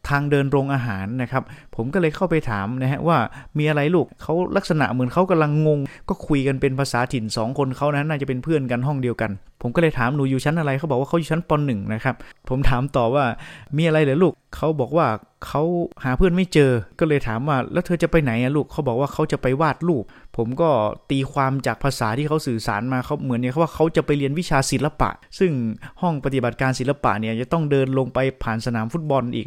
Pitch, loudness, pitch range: 140 Hz, -21 LUFS, 125-155 Hz